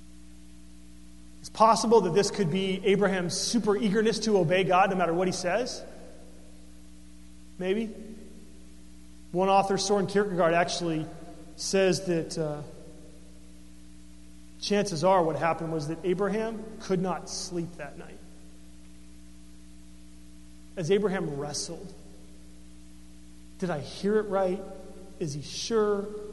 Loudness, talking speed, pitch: -27 LUFS, 110 wpm, 165 Hz